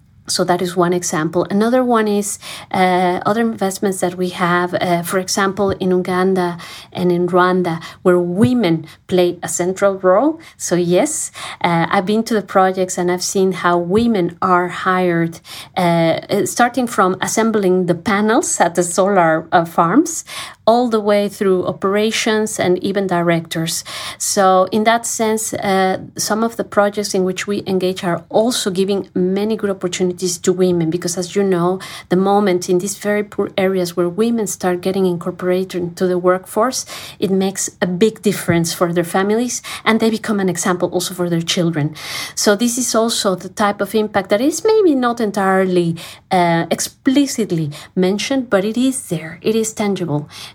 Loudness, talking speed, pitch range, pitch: -17 LUFS, 170 wpm, 180-210 Hz, 190 Hz